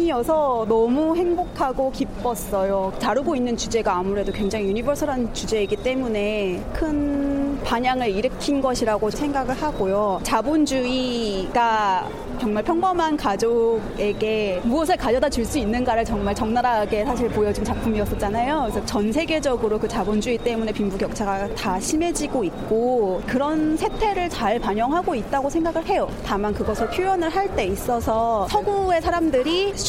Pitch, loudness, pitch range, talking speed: 240 Hz, -22 LUFS, 215-295 Hz, 340 characters per minute